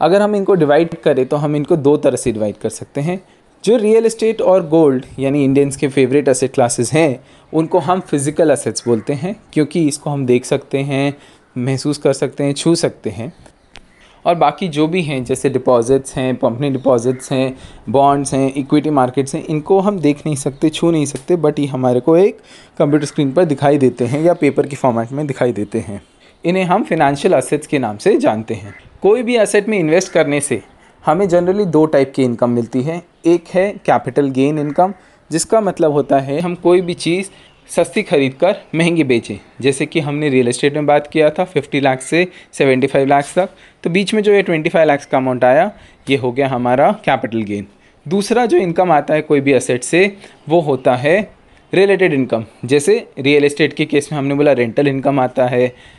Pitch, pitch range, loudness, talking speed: 145 Hz, 130-170 Hz, -15 LUFS, 200 wpm